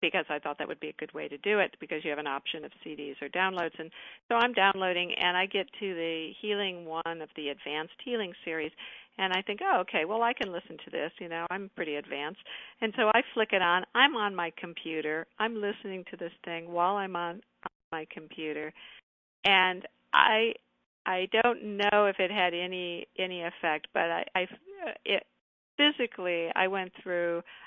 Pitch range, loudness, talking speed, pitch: 165-205 Hz, -30 LUFS, 200 wpm, 180 Hz